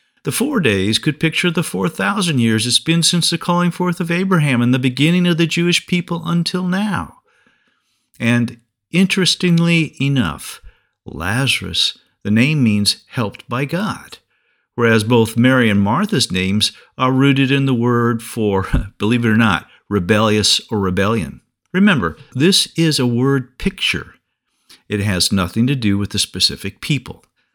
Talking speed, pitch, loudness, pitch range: 150 wpm, 125 Hz, -16 LUFS, 110-170 Hz